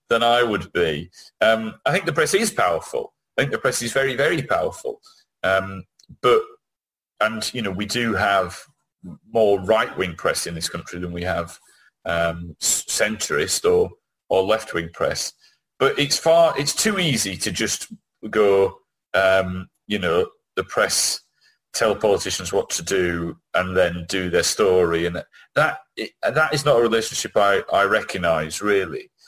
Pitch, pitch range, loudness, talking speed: 110 Hz, 90-145 Hz, -21 LUFS, 160 wpm